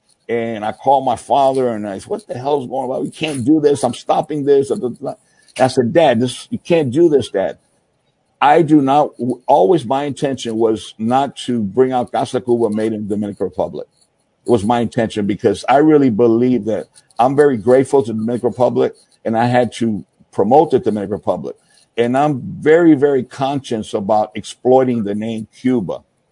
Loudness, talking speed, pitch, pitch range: -16 LUFS, 190 wpm, 125 Hz, 115-140 Hz